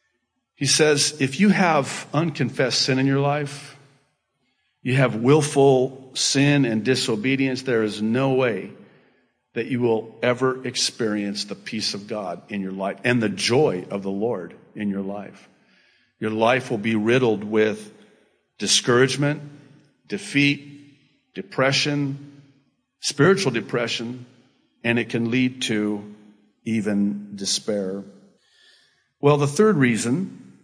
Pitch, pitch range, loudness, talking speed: 130 Hz, 110-140 Hz, -22 LUFS, 125 wpm